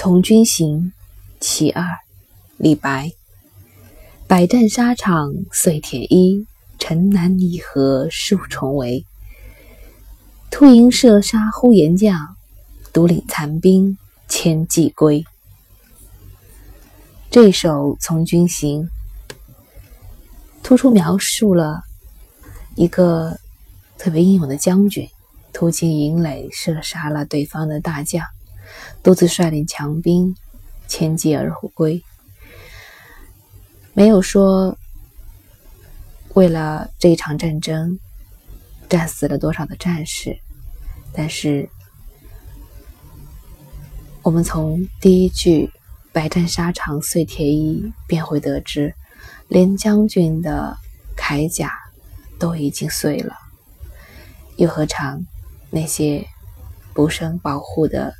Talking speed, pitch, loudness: 140 characters per minute, 155 Hz, -16 LUFS